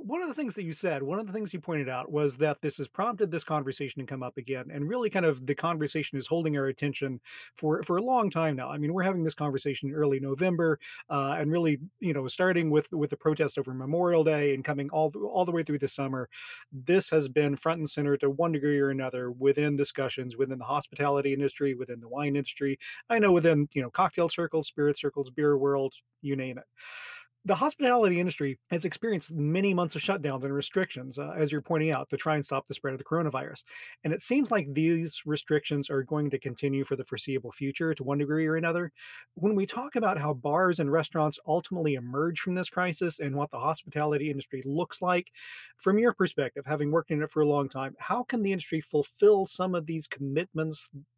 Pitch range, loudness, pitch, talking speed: 140-175 Hz, -29 LUFS, 150 Hz, 225 wpm